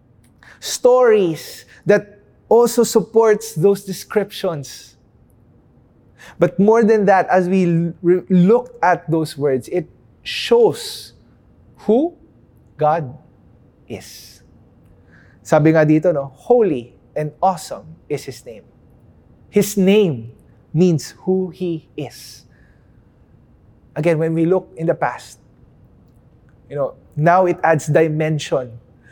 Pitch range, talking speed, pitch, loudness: 125-190 Hz, 105 wpm, 160 Hz, -17 LUFS